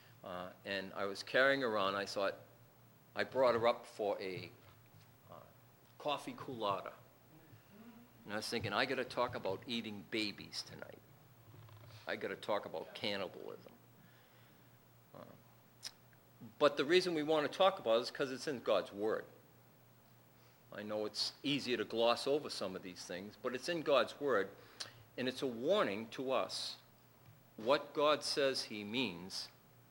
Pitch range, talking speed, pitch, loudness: 110-140 Hz, 150 wpm, 120 Hz, -38 LUFS